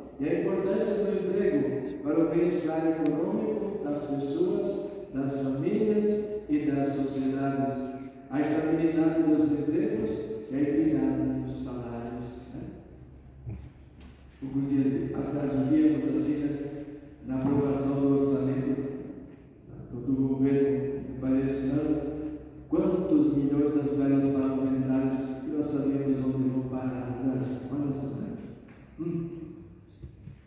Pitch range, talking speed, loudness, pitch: 135-150 Hz, 100 wpm, -28 LUFS, 140 Hz